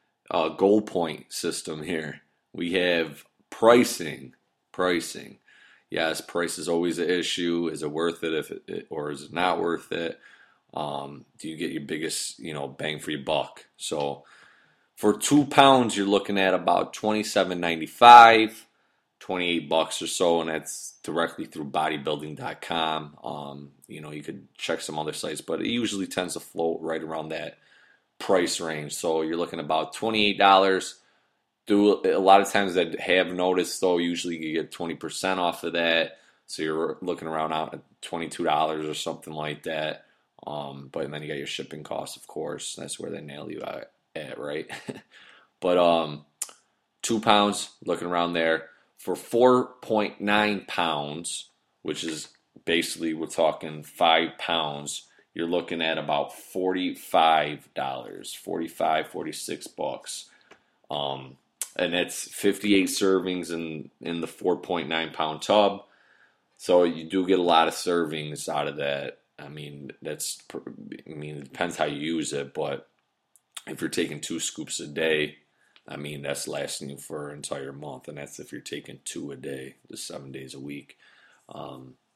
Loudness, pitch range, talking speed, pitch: -25 LUFS, 75-95 Hz, 160 wpm, 80 Hz